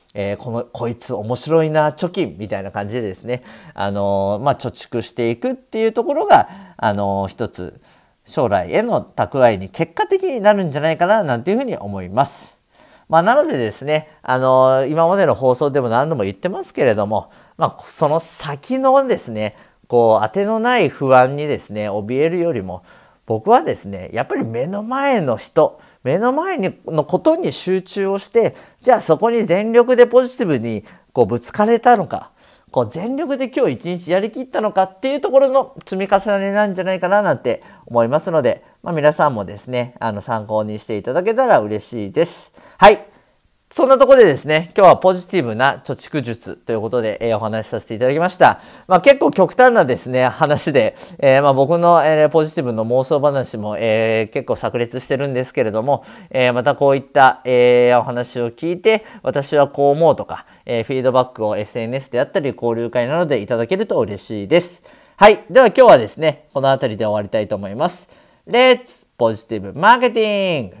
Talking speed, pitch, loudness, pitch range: 380 characters per minute, 140 Hz, -16 LUFS, 115-195 Hz